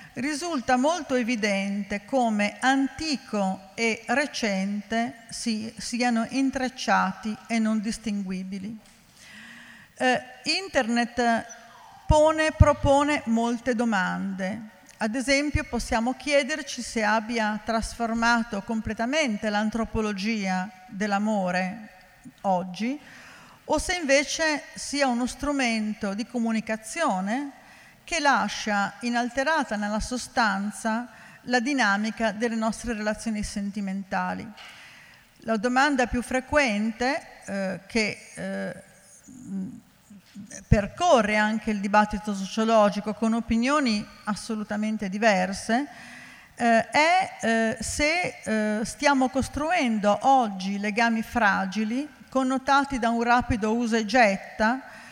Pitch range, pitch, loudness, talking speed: 210-255 Hz, 230 Hz, -25 LUFS, 90 wpm